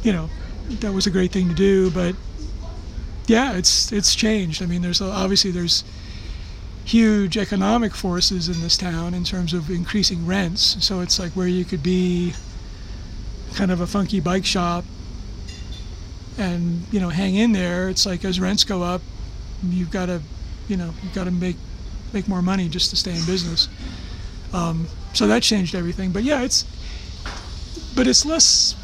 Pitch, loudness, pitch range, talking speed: 180 Hz, -20 LUFS, 160-195 Hz, 175 wpm